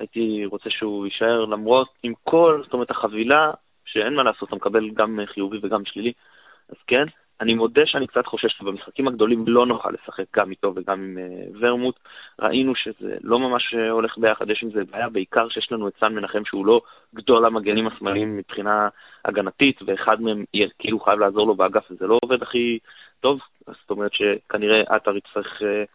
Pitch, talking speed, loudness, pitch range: 110 Hz, 180 wpm, -21 LUFS, 105-120 Hz